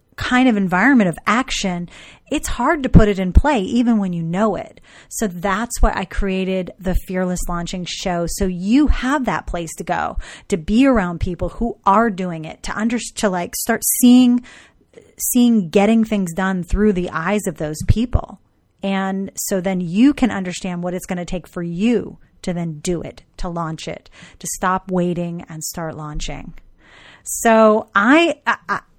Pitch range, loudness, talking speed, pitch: 180-230 Hz, -18 LUFS, 180 wpm, 195 Hz